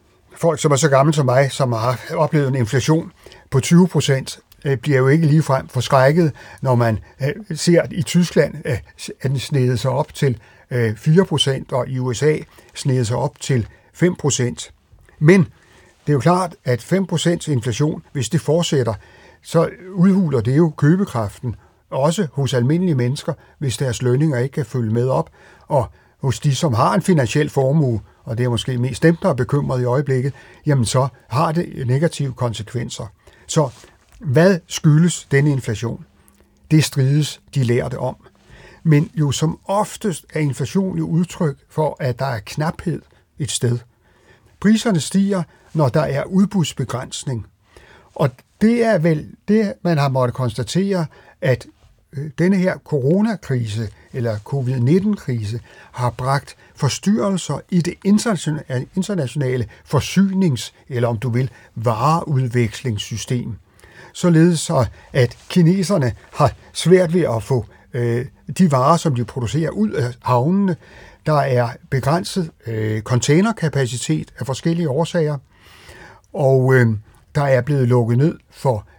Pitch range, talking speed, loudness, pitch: 125-165 Hz, 135 wpm, -19 LUFS, 135 Hz